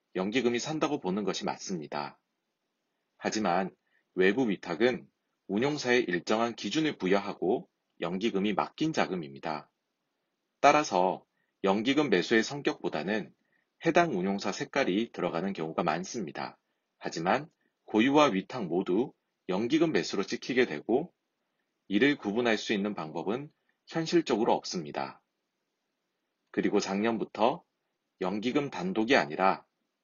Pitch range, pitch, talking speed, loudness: 100-150 Hz, 120 Hz, 275 characters per minute, -30 LUFS